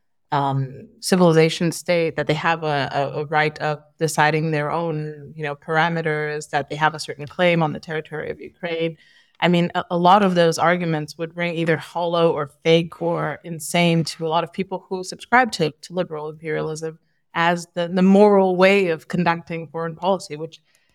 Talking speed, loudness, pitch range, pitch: 185 wpm, -21 LUFS, 150-175 Hz, 165 Hz